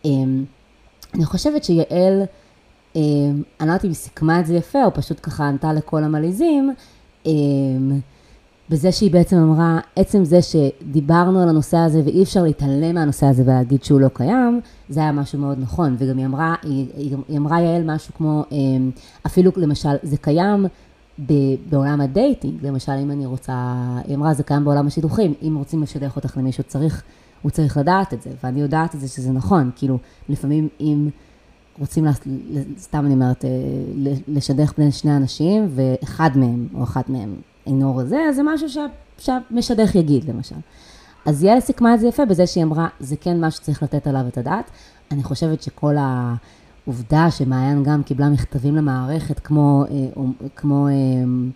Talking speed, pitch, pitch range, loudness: 165 wpm, 145 Hz, 135-165 Hz, -19 LUFS